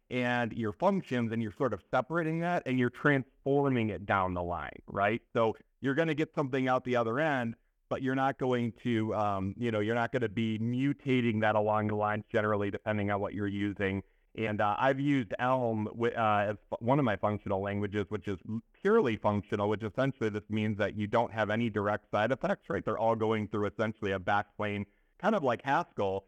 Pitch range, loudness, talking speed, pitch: 105-130 Hz, -31 LUFS, 210 wpm, 110 Hz